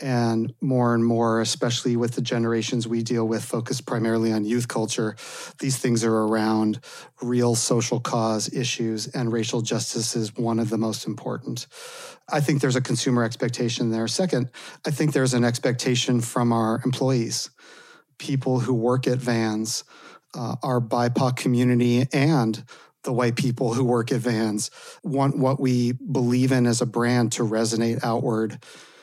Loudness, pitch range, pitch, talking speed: -23 LUFS, 115-130 Hz, 120 Hz, 160 wpm